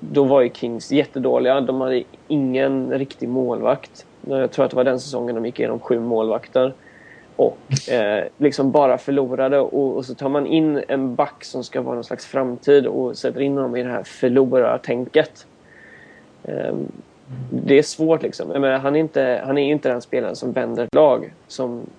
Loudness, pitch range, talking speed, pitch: -20 LUFS, 125-140 Hz, 185 wpm, 130 Hz